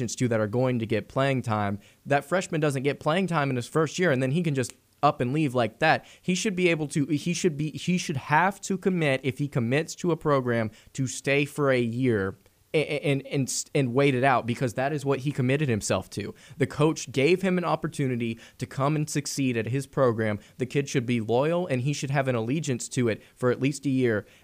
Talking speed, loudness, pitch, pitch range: 240 wpm, -26 LUFS, 135 Hz, 120-150 Hz